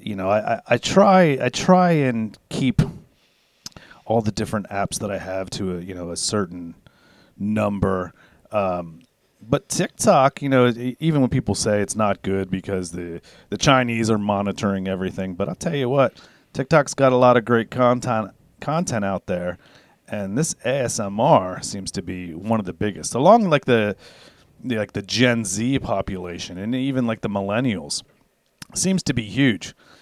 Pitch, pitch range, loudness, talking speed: 110 Hz, 95-125 Hz, -21 LUFS, 170 wpm